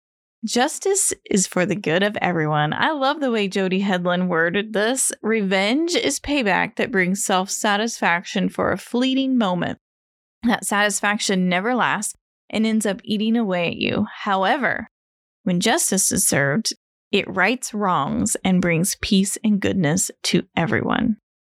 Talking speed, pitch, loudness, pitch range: 140 wpm, 205 Hz, -20 LUFS, 185-235 Hz